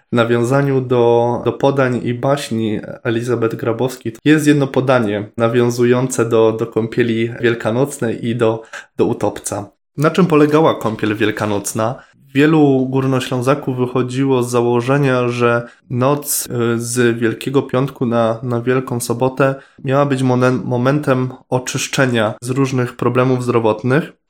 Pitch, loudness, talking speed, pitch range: 125 Hz, -16 LUFS, 120 wpm, 115-135 Hz